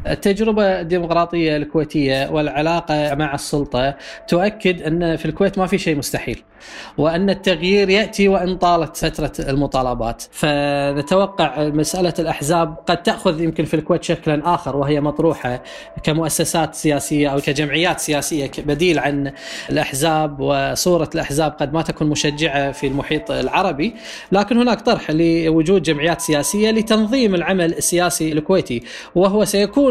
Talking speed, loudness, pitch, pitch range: 125 wpm, -18 LUFS, 160 Hz, 150-180 Hz